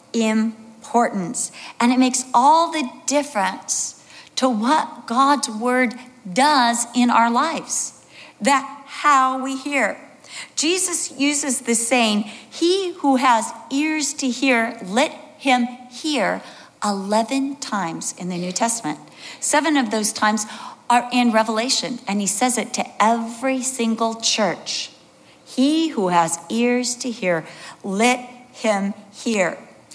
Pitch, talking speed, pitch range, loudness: 245 Hz, 125 wpm, 225-275 Hz, -20 LUFS